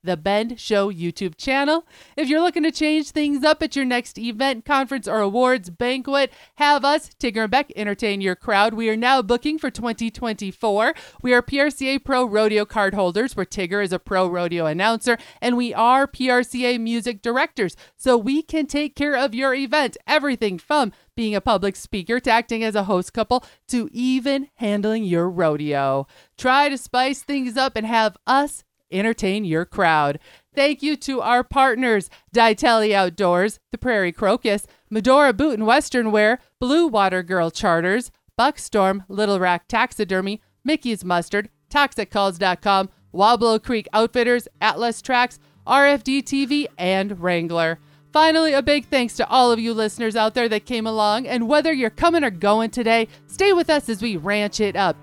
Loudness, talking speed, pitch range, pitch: -20 LUFS, 170 wpm, 205-270 Hz, 230 Hz